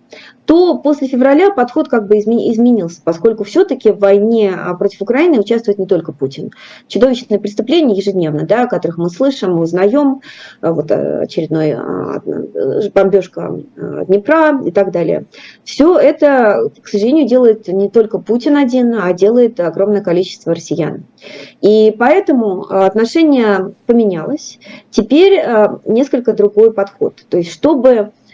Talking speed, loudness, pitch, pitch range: 125 wpm, -12 LUFS, 220 Hz, 195-270 Hz